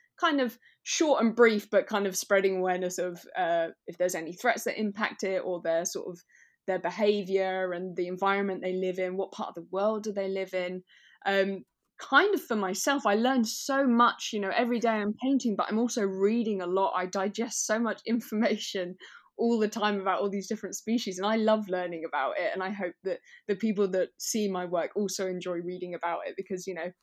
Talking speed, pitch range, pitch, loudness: 220 wpm, 185-225 Hz, 200 Hz, -29 LUFS